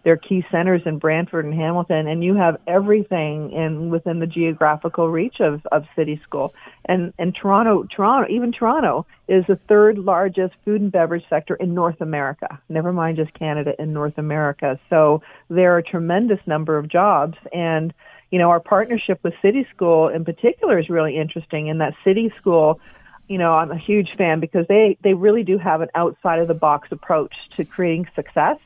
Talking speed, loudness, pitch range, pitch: 190 wpm, -19 LUFS, 160-190 Hz, 170 Hz